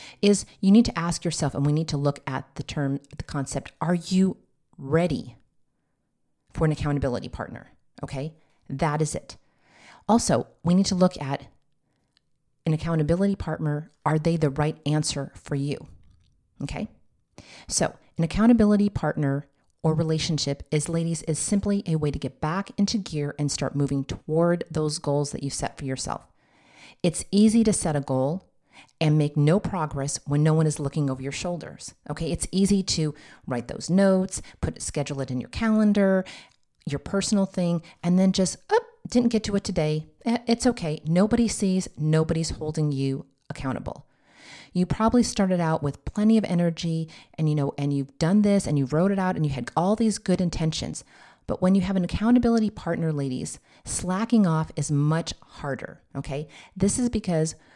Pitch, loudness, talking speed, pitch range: 160 Hz, -25 LUFS, 175 wpm, 145-190 Hz